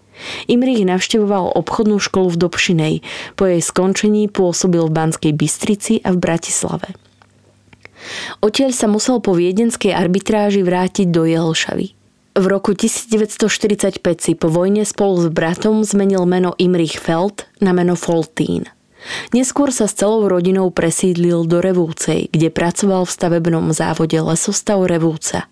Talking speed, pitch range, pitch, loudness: 130 wpm, 170-210 Hz, 185 Hz, -16 LUFS